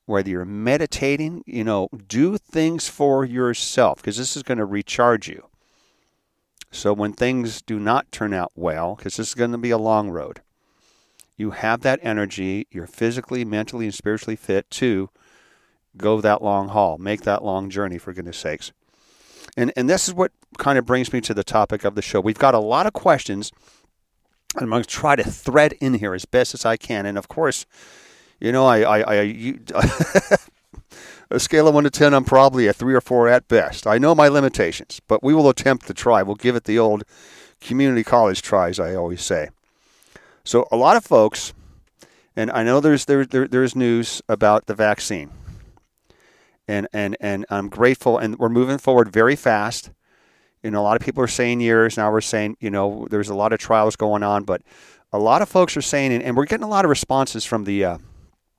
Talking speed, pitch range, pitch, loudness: 205 wpm, 105-130 Hz, 115 Hz, -19 LUFS